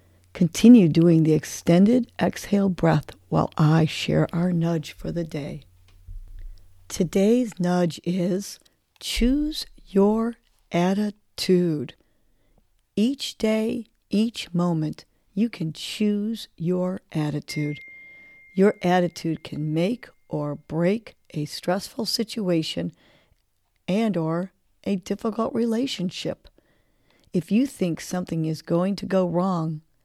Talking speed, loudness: 105 wpm, -24 LUFS